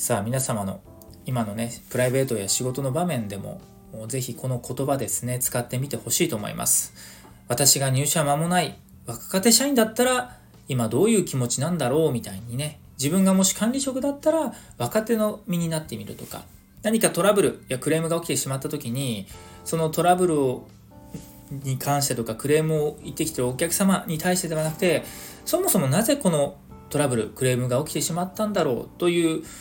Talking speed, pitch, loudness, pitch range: 385 characters per minute, 145 Hz, -23 LUFS, 120-175 Hz